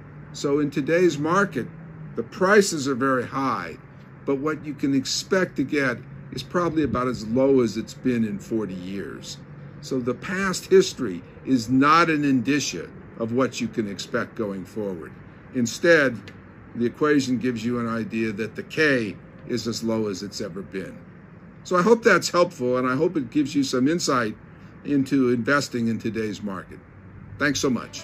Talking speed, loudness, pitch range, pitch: 170 wpm, -23 LUFS, 115-155 Hz, 130 Hz